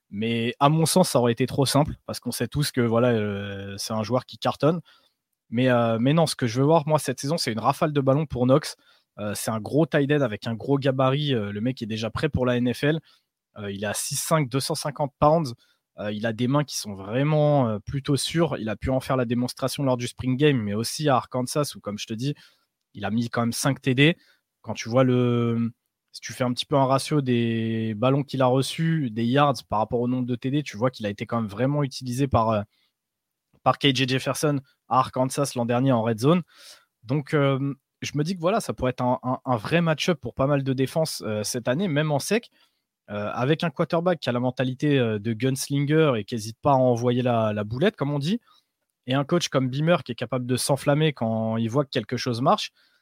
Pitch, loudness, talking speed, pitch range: 130 Hz, -24 LUFS, 240 wpm, 120-145 Hz